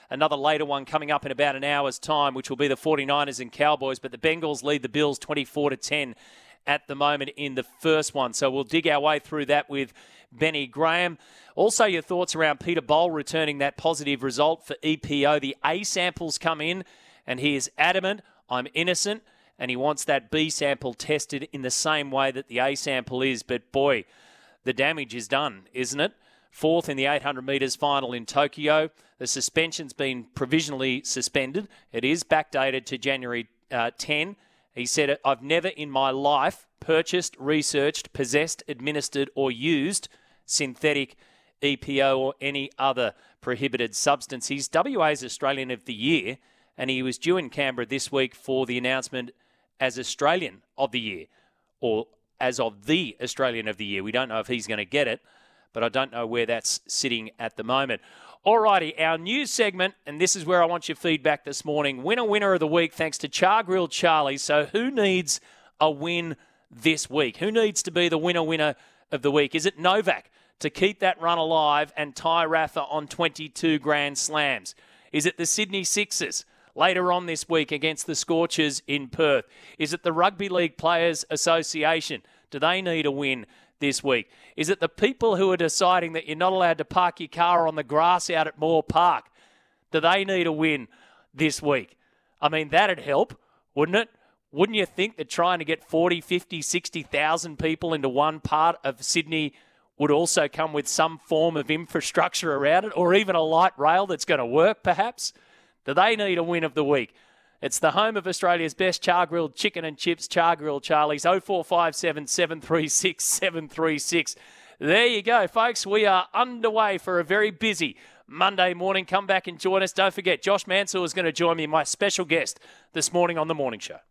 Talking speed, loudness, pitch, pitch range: 190 wpm, -24 LUFS, 155 Hz, 140-175 Hz